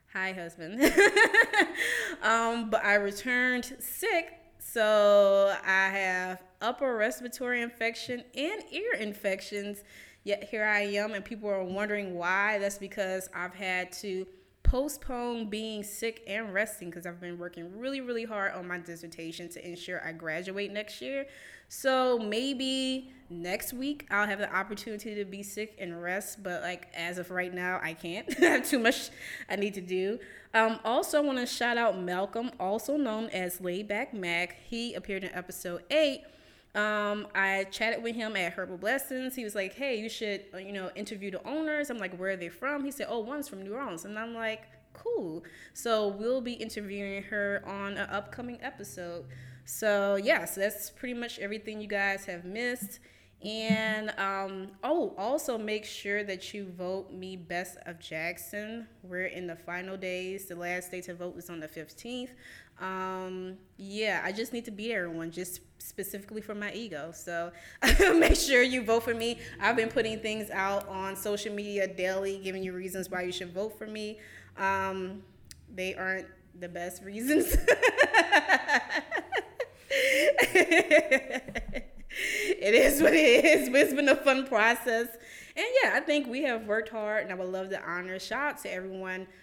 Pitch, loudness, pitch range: 205 Hz, -29 LUFS, 185-245 Hz